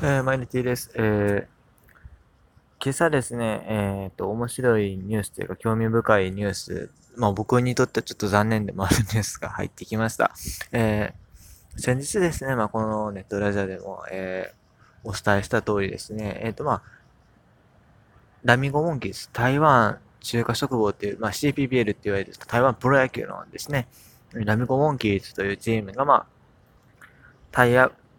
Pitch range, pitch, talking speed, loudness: 100-125 Hz, 110 Hz, 360 characters per minute, -24 LUFS